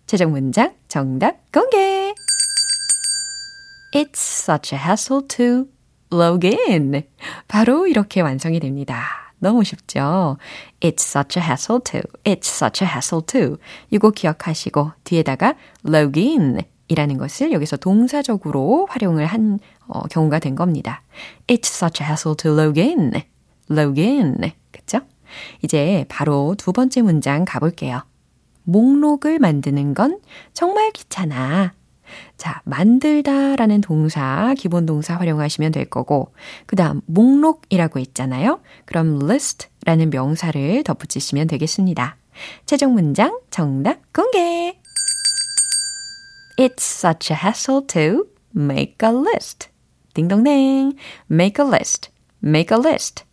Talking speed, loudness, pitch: 310 characters per minute, -18 LUFS, 185 Hz